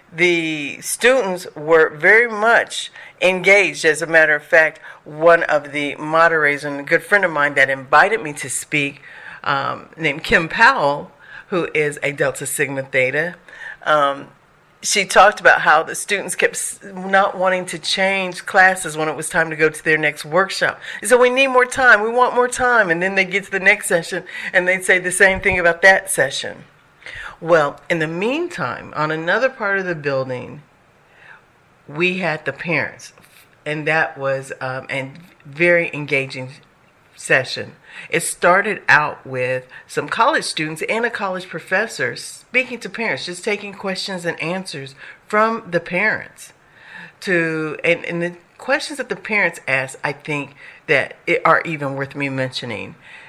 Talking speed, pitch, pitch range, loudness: 165 wpm, 170 Hz, 150-195 Hz, -17 LUFS